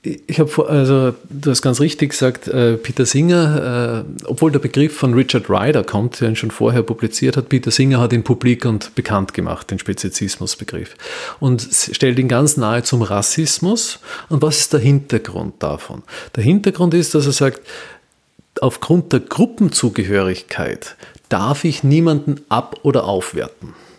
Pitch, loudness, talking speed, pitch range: 130 Hz, -16 LUFS, 155 wpm, 115-150 Hz